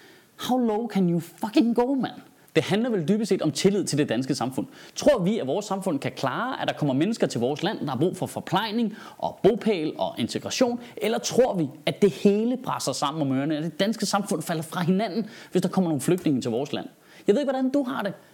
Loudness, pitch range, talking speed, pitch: -25 LUFS, 170-230 Hz, 240 wpm, 200 Hz